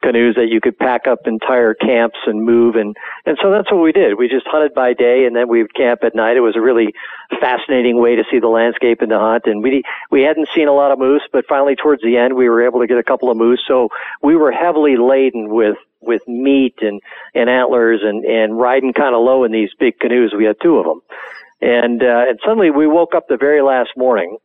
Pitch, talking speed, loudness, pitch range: 125 Hz, 250 wpm, -13 LUFS, 115-140 Hz